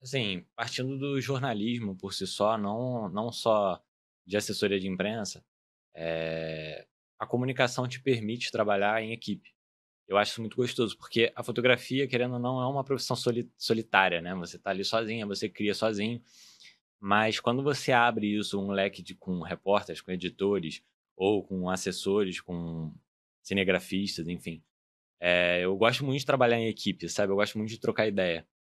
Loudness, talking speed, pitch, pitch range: -29 LUFS, 165 wpm, 105 Hz, 95-120 Hz